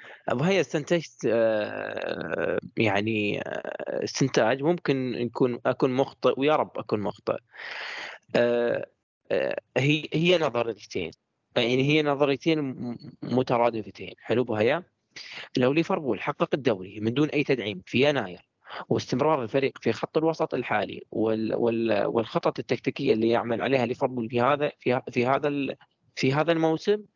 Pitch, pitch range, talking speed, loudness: 130 Hz, 115-150 Hz, 120 wpm, -26 LUFS